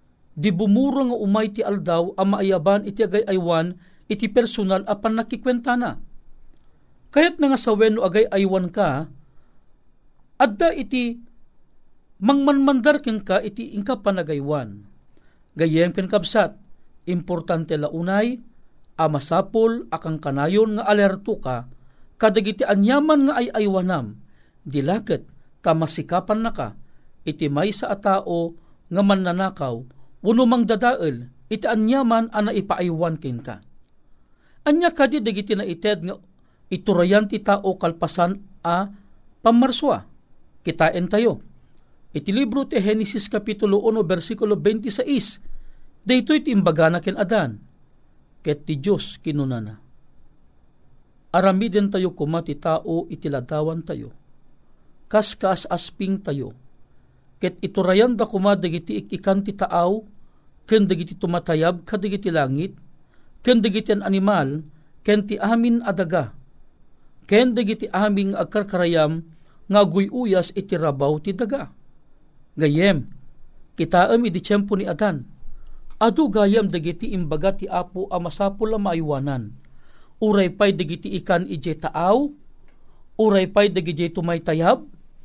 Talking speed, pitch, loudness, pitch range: 115 wpm, 195 Hz, -21 LUFS, 165-220 Hz